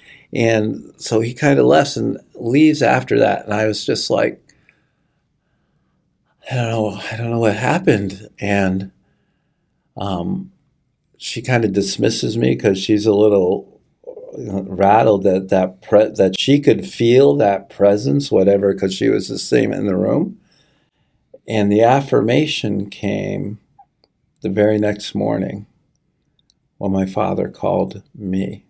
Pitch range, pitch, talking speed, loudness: 100-140 Hz, 110 Hz, 140 wpm, -17 LUFS